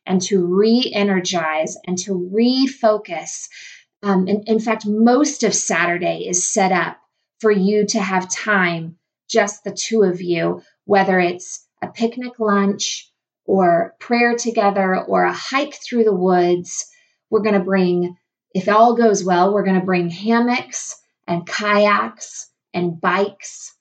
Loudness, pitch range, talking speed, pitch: -18 LUFS, 180-225 Hz, 145 wpm, 200 Hz